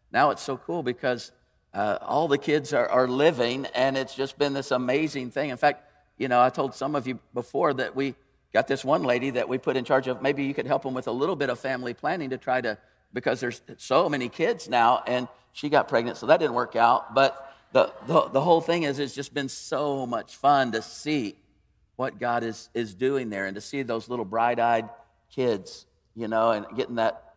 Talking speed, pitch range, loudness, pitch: 230 wpm, 120-135 Hz, -26 LUFS, 130 Hz